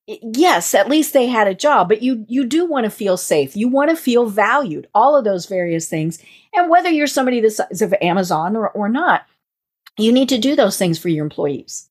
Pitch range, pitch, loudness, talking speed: 195-285 Hz, 230 Hz, -16 LUFS, 220 wpm